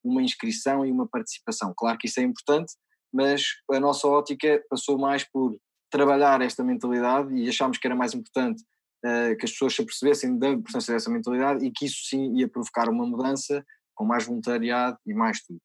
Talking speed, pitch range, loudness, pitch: 190 wpm, 125-145 Hz, -25 LUFS, 135 Hz